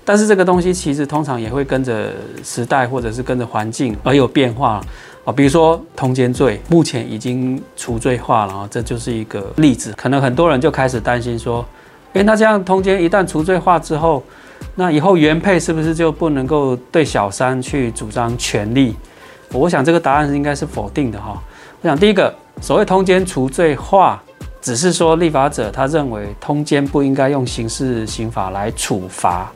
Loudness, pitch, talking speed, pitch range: -16 LUFS, 135 Hz, 290 characters per minute, 120-165 Hz